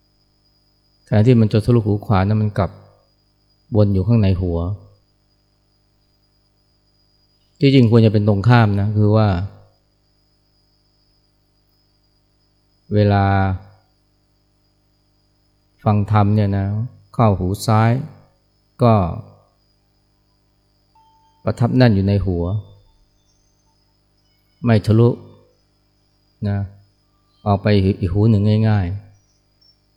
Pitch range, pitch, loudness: 100-105 Hz, 100 Hz, -17 LUFS